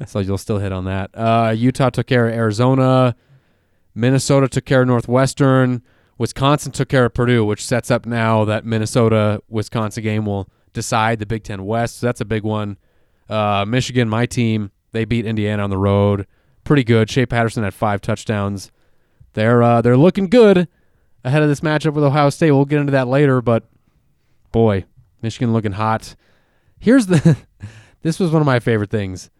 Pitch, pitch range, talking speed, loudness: 115 Hz, 105-130 Hz, 180 wpm, -17 LUFS